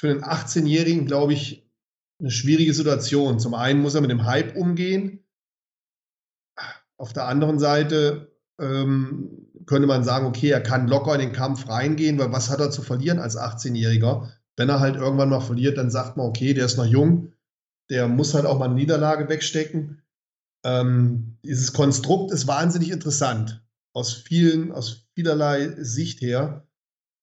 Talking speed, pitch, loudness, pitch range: 165 wpm, 140 Hz, -22 LUFS, 125-150 Hz